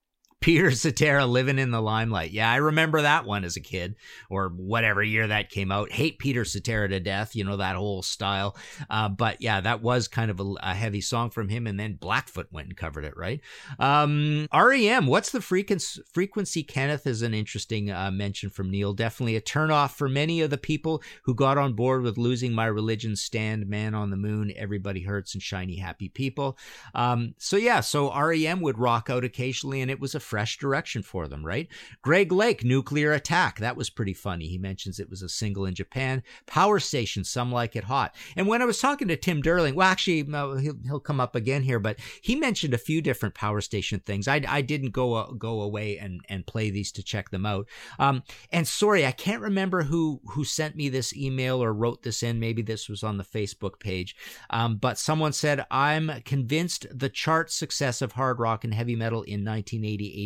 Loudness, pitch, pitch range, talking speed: -26 LUFS, 120 Hz, 105-145 Hz, 210 wpm